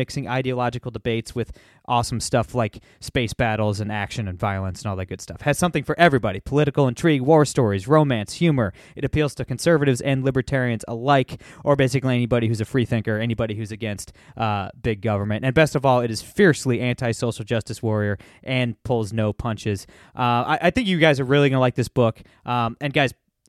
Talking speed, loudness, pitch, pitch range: 200 wpm, -22 LUFS, 120 Hz, 110-135 Hz